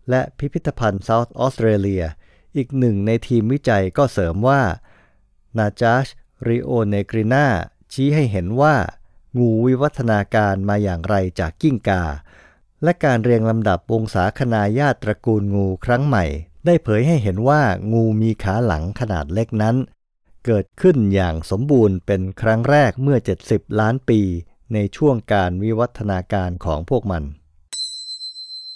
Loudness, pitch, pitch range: -19 LUFS, 110 Hz, 95-125 Hz